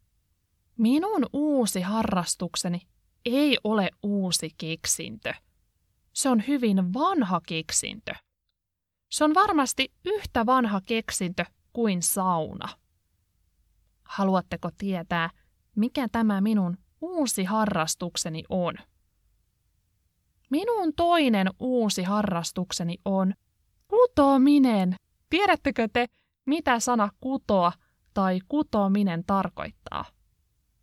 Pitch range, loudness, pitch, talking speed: 175-255 Hz, -26 LUFS, 200 Hz, 80 wpm